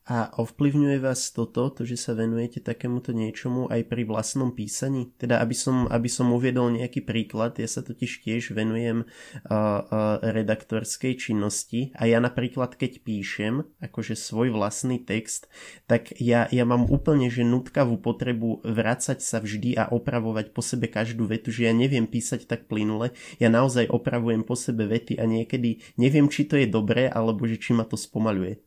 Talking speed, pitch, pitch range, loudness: 170 wpm, 120 Hz, 115-125 Hz, -25 LUFS